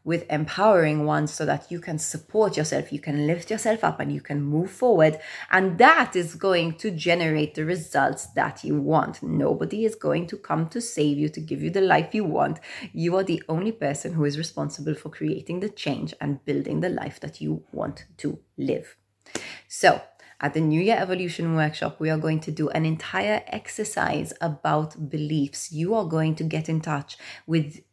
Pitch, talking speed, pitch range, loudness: 160 Hz, 195 wpm, 150-185 Hz, -25 LUFS